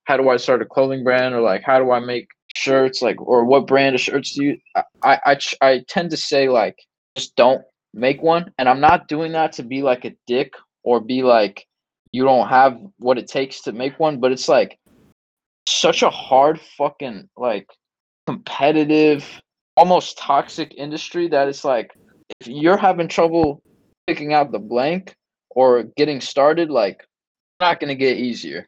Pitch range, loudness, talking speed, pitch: 130-160 Hz, -18 LUFS, 180 wpm, 135 Hz